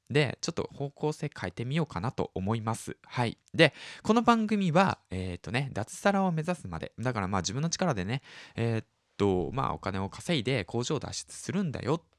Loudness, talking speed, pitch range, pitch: -30 LUFS, 375 characters per minute, 95-165 Hz, 130 Hz